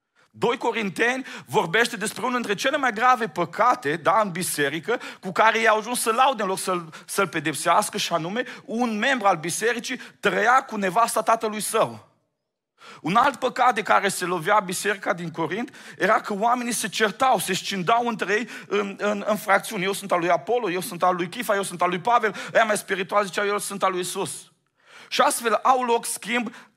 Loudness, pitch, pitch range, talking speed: -23 LUFS, 215 Hz, 190-240 Hz, 195 wpm